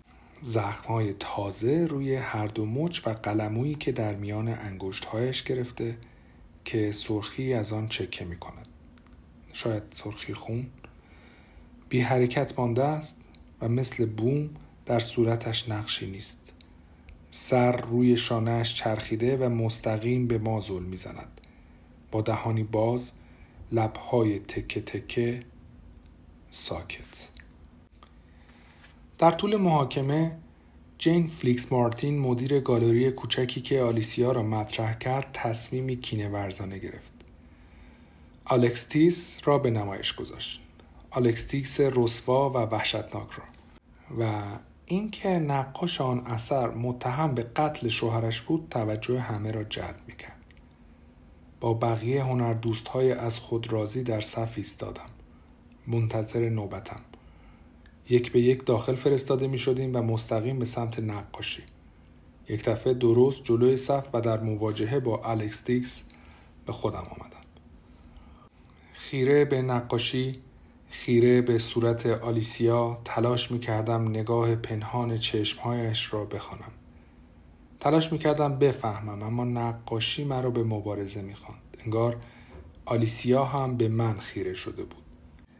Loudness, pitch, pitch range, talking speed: -28 LUFS, 115 Hz, 100-125 Hz, 115 wpm